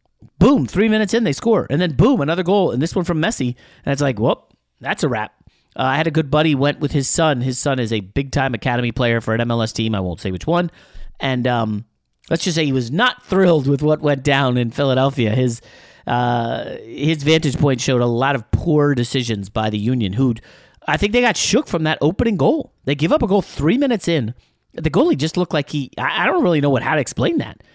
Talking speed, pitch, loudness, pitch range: 240 wpm, 140 Hz, -18 LUFS, 120-160 Hz